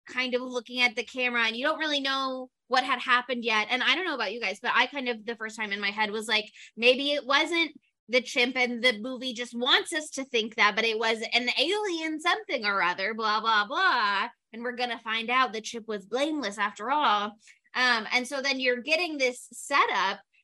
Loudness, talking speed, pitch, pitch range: -26 LUFS, 230 wpm, 245 Hz, 225-275 Hz